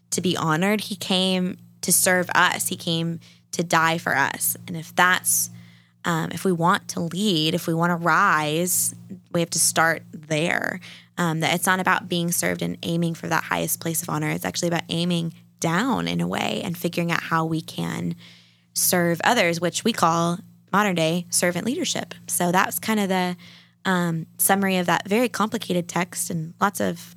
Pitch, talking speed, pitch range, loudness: 170 Hz, 190 wpm, 160-185 Hz, -22 LUFS